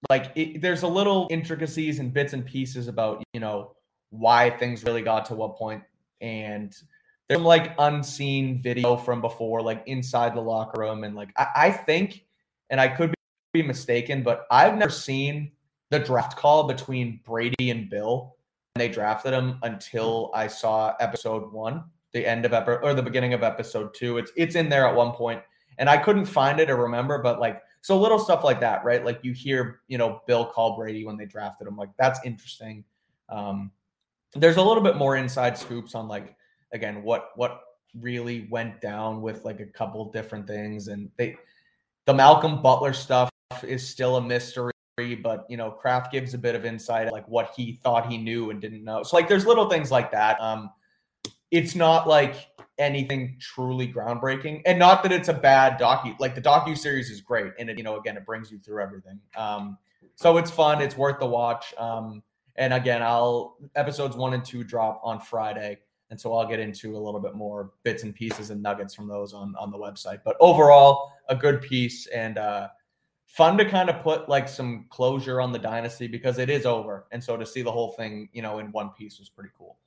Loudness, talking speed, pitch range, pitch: -24 LUFS, 205 wpm, 110-140 Hz, 120 Hz